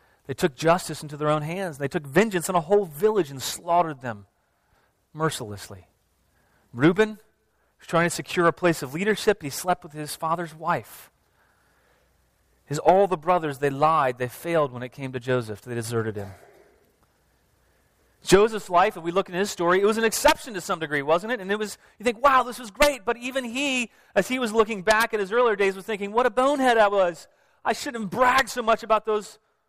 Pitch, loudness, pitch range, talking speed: 175 Hz, -24 LUFS, 145-215 Hz, 205 wpm